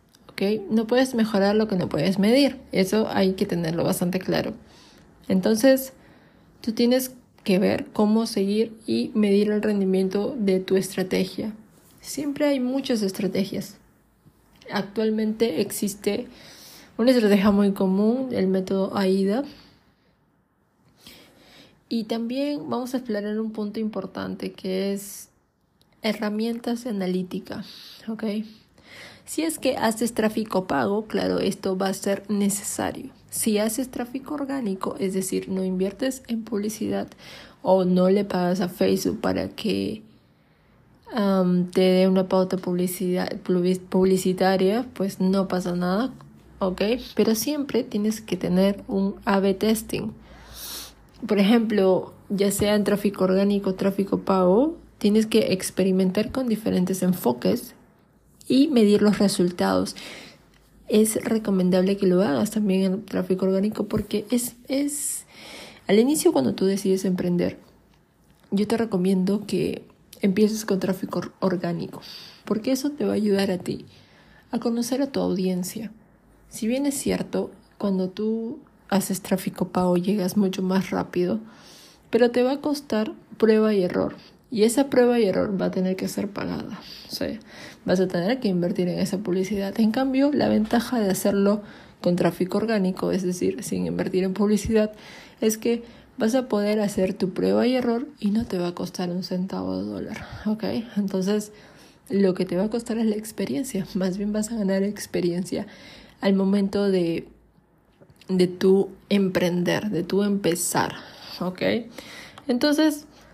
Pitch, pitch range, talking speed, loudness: 205 Hz, 190-225 Hz, 140 wpm, -24 LUFS